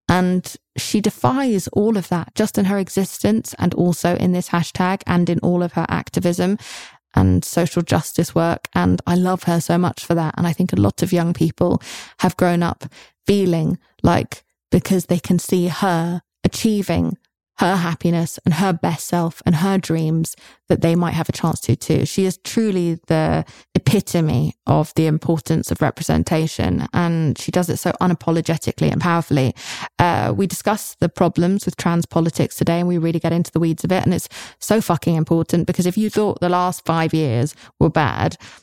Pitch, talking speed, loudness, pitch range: 170 Hz, 185 wpm, -19 LUFS, 160-180 Hz